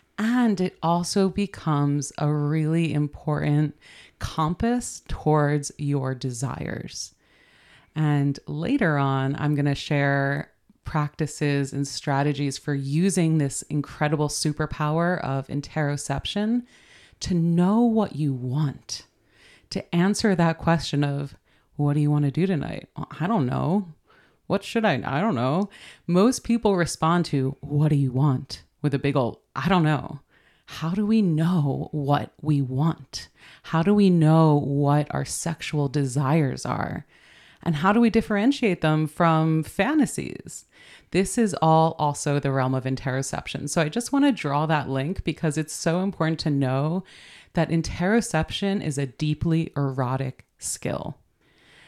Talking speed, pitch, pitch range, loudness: 140 wpm, 150 Hz, 140-170 Hz, -24 LUFS